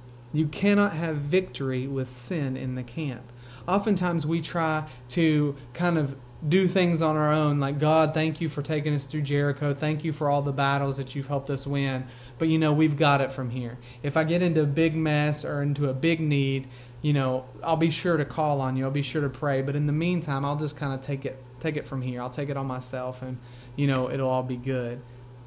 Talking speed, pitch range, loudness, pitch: 235 wpm, 130-155 Hz, -26 LUFS, 145 Hz